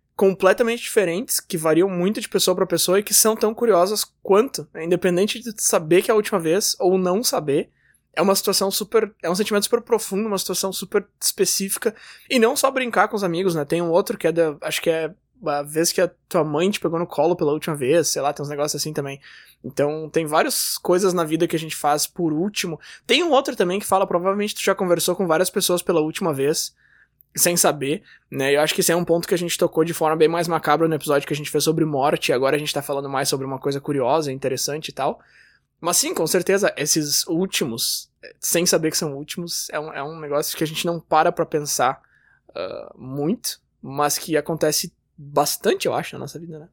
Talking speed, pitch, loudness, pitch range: 230 wpm, 170 Hz, -21 LUFS, 150-195 Hz